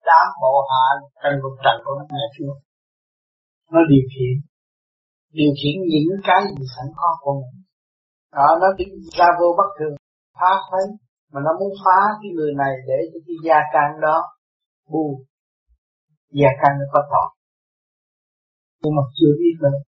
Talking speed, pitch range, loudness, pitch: 165 wpm, 135-170 Hz, -18 LUFS, 145 Hz